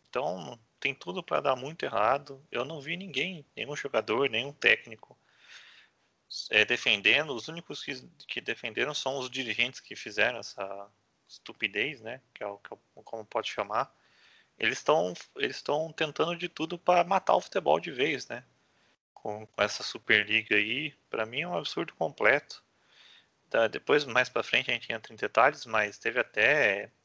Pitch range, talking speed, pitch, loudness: 115-160 Hz, 175 wpm, 140 Hz, -29 LUFS